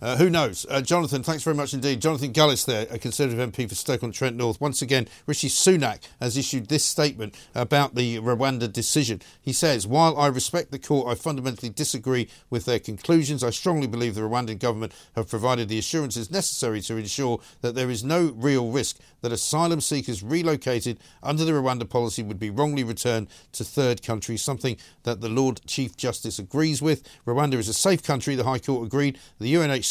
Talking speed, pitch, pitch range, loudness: 195 wpm, 130 Hz, 115-145 Hz, -25 LUFS